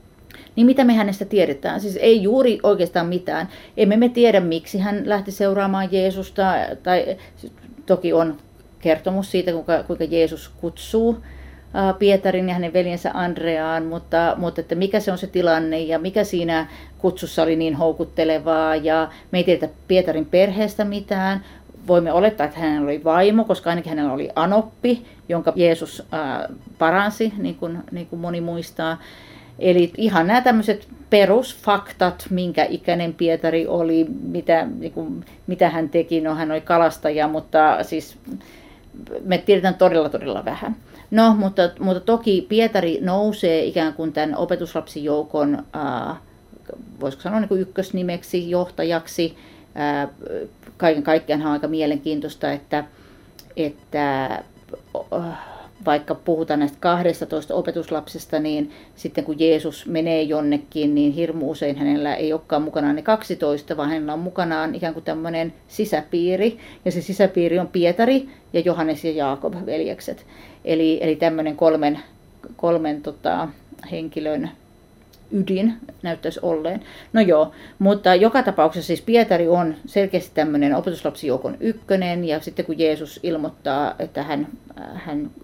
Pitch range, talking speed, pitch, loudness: 160-190 Hz, 135 wpm, 170 Hz, -20 LUFS